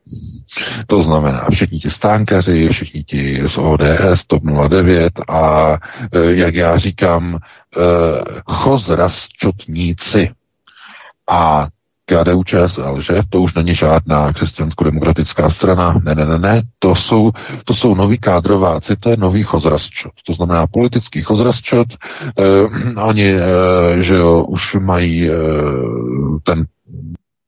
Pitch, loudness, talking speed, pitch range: 85 Hz, -13 LUFS, 115 wpm, 80-100 Hz